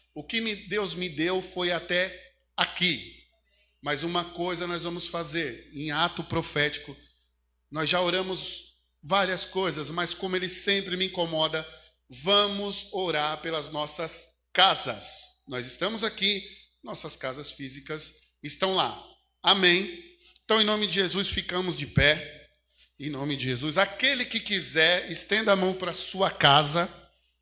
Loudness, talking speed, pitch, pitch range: -26 LUFS, 140 wpm, 175 Hz, 150-190 Hz